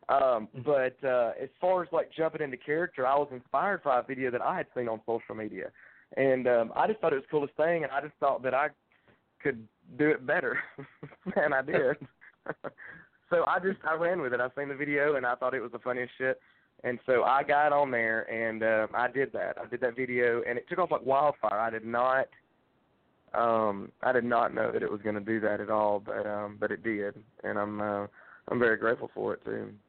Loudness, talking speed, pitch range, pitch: -30 LUFS, 235 wpm, 110-150 Hz, 125 Hz